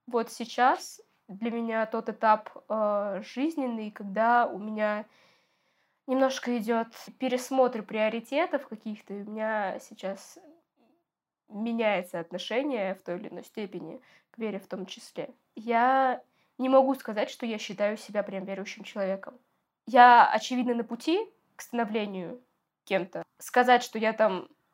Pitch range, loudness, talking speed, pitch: 210-255 Hz, -28 LUFS, 130 wpm, 230 Hz